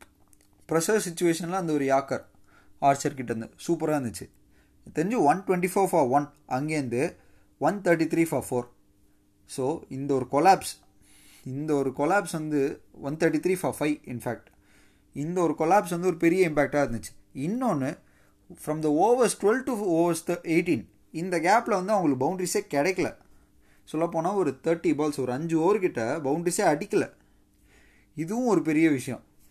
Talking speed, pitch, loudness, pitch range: 140 wpm, 150 Hz, -26 LUFS, 120-170 Hz